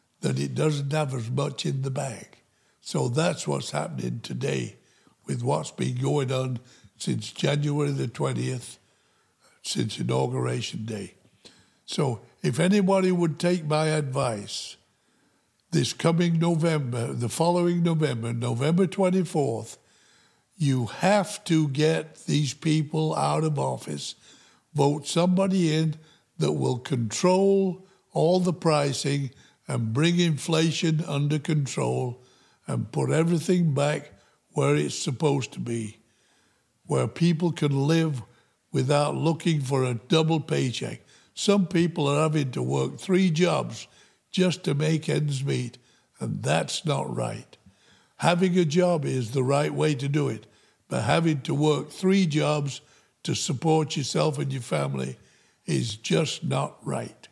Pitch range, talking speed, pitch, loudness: 125-165 Hz, 130 wpm, 150 Hz, -26 LUFS